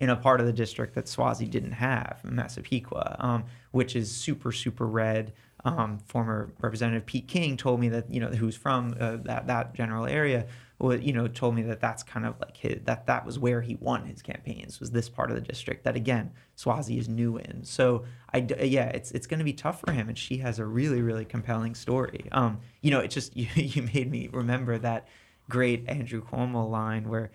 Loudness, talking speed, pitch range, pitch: -29 LUFS, 215 wpm, 115-130 Hz, 120 Hz